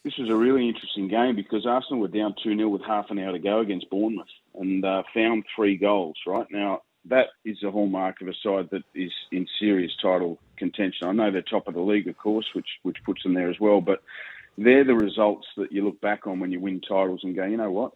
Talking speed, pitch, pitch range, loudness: 245 wpm, 100 Hz, 95-105 Hz, -25 LUFS